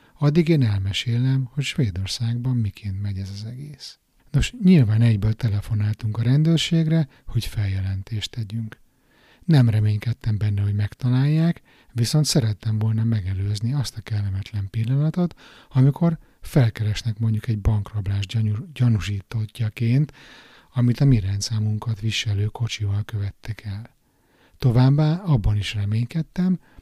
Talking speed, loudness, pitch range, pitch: 110 wpm, -22 LUFS, 105-135 Hz, 115 Hz